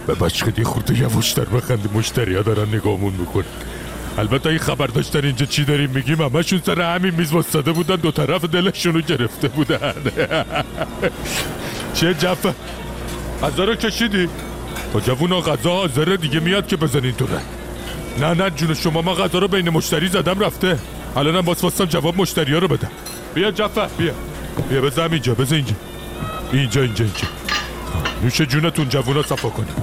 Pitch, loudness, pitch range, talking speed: 155 Hz, -19 LUFS, 125-180 Hz, 155 wpm